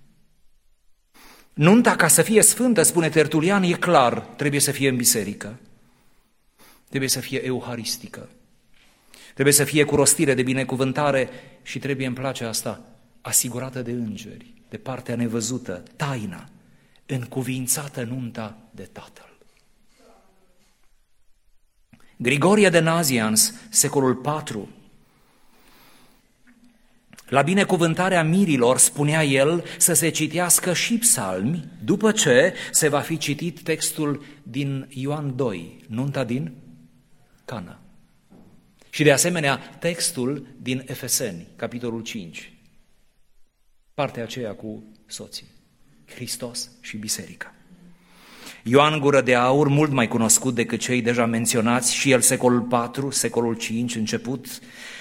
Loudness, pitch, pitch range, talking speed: -20 LUFS, 135 Hz, 120-155 Hz, 110 wpm